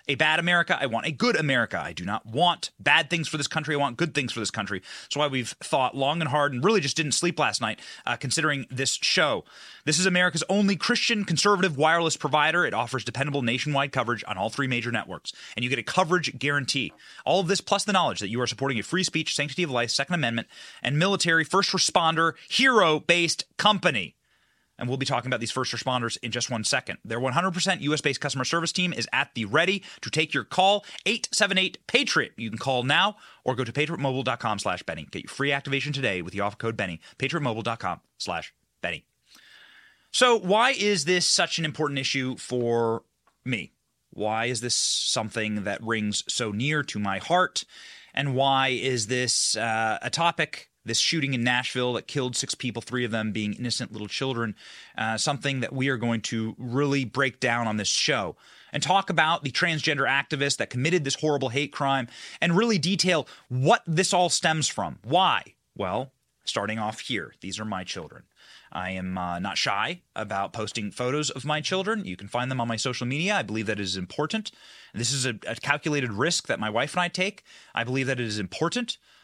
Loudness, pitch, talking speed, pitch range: -25 LUFS, 135 Hz, 205 wpm, 115-165 Hz